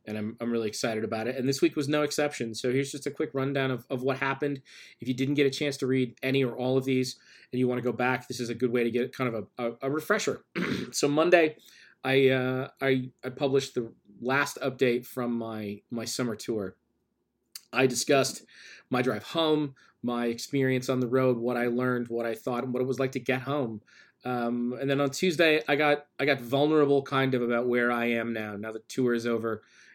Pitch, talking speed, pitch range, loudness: 130 Hz, 230 wpm, 120-140 Hz, -28 LUFS